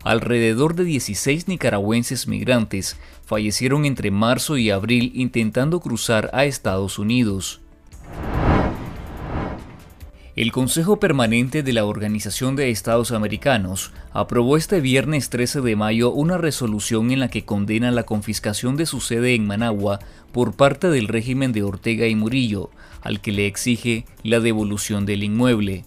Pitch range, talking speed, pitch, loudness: 105-130 Hz, 135 wpm, 115 Hz, -20 LUFS